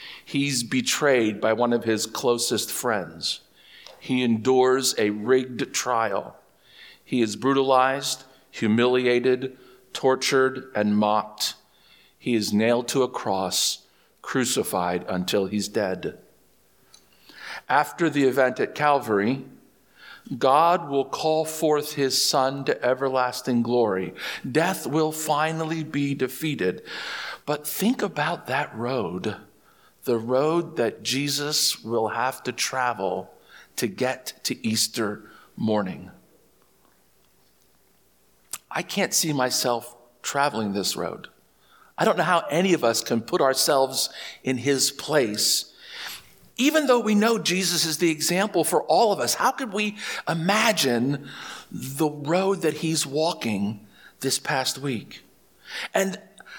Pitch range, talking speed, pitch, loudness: 120-155 Hz, 120 wpm, 130 Hz, -24 LUFS